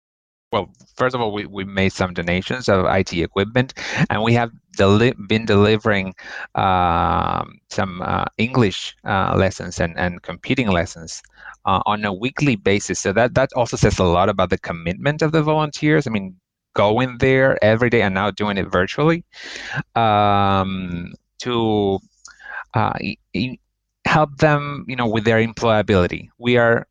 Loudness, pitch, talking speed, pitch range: -19 LUFS, 105 Hz, 155 wpm, 95-125 Hz